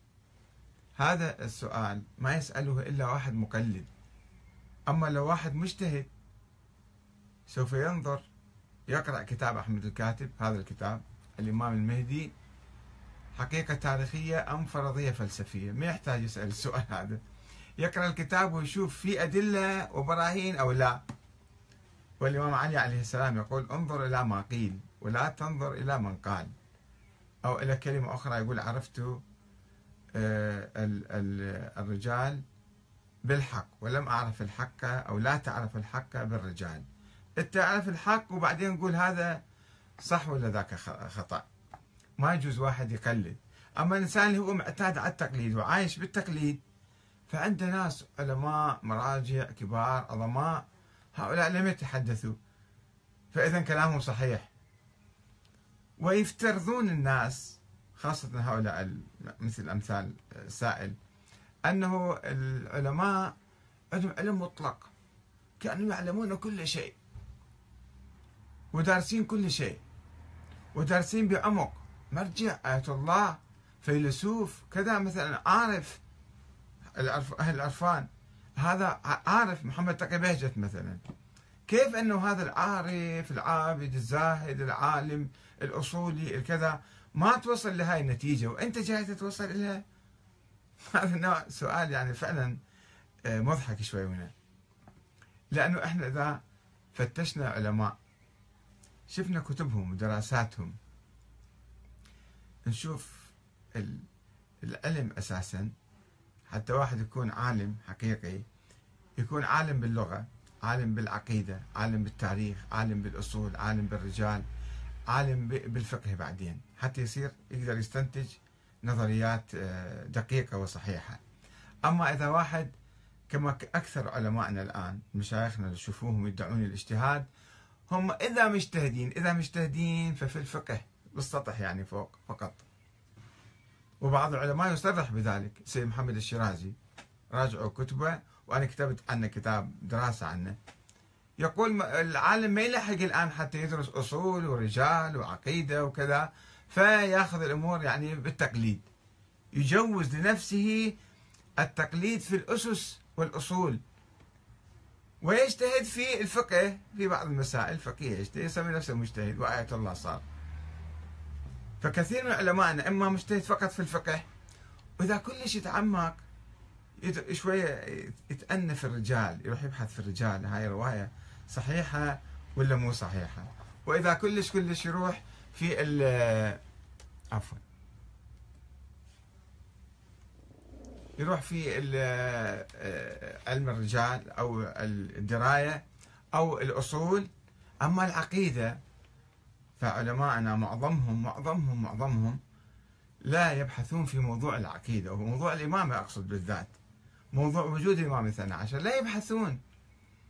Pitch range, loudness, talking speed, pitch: 105-160 Hz, -32 LUFS, 100 wpm, 125 Hz